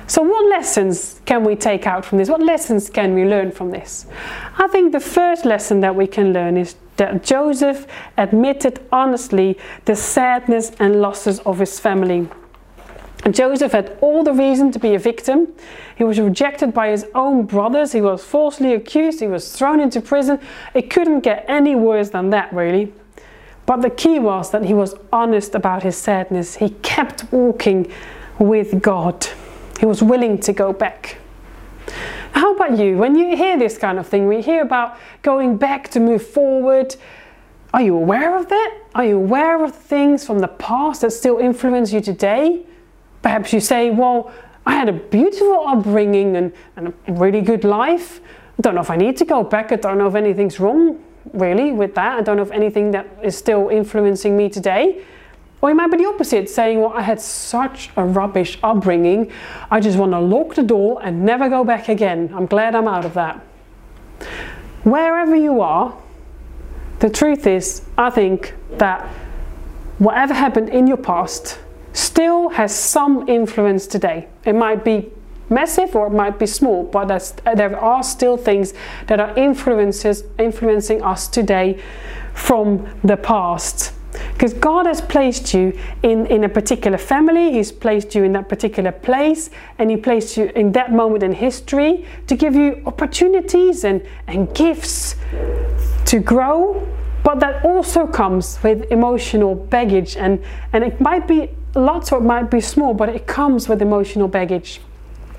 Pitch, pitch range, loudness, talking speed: 220 Hz, 200-275 Hz, -16 LUFS, 175 wpm